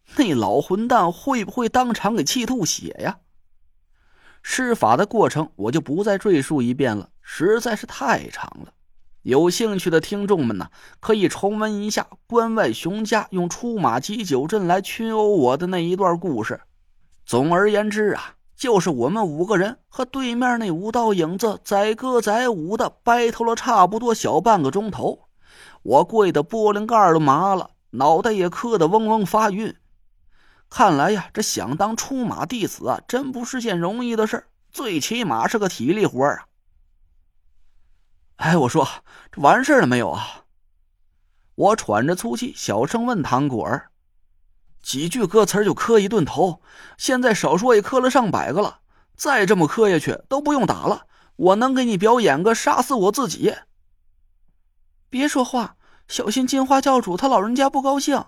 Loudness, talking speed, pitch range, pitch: -20 LUFS, 240 characters per minute, 165-235 Hz, 215 Hz